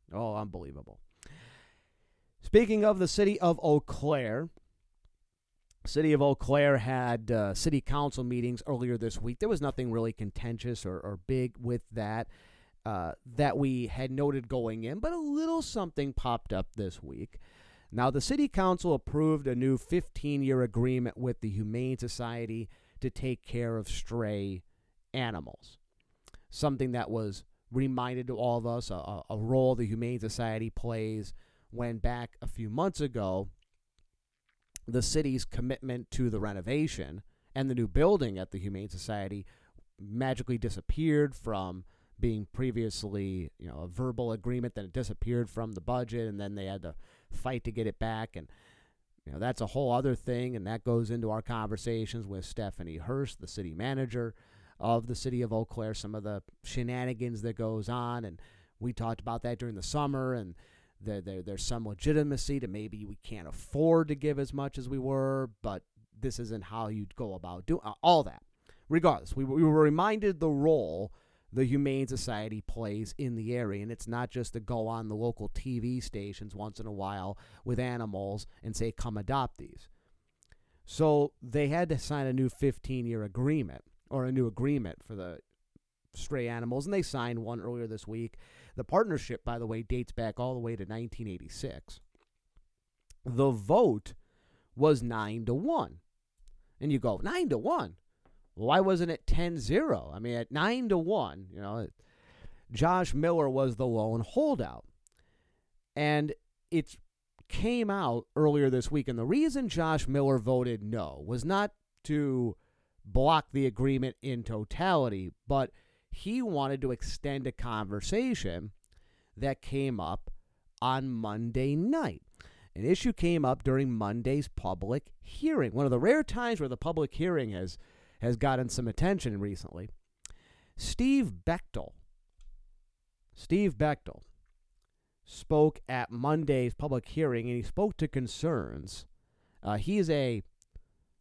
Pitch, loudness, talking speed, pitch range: 120 Hz, -32 LUFS, 160 wpm, 105-135 Hz